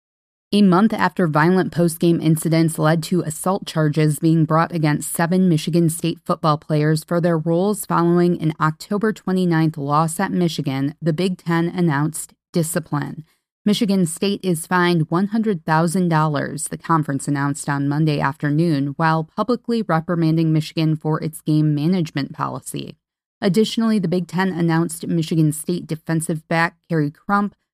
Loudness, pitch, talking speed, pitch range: -19 LUFS, 165 Hz, 140 wpm, 155-180 Hz